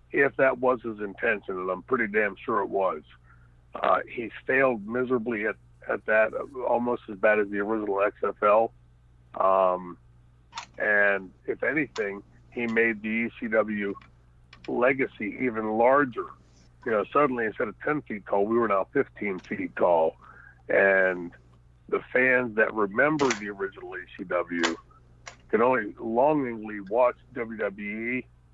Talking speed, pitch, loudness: 135 wpm, 100 Hz, -26 LUFS